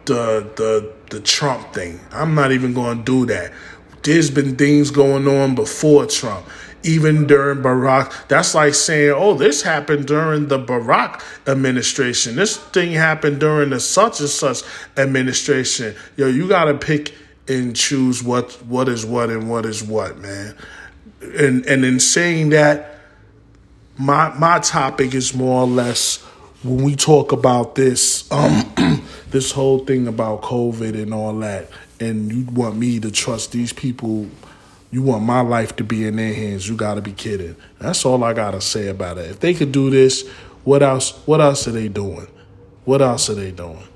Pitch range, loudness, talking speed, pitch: 110-145 Hz, -17 LUFS, 170 wpm, 130 Hz